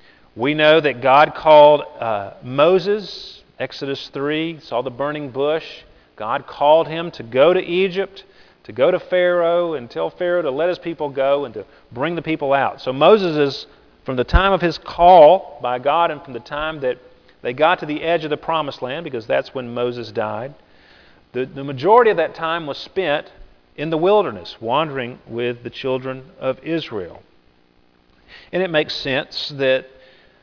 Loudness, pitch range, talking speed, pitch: -18 LUFS, 130-165 Hz, 175 wpm, 145 Hz